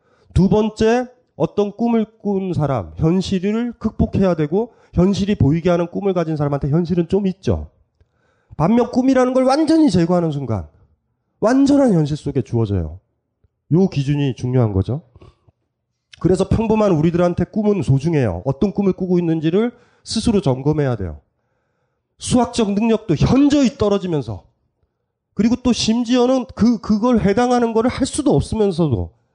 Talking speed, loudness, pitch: 310 characters per minute, -18 LUFS, 180 Hz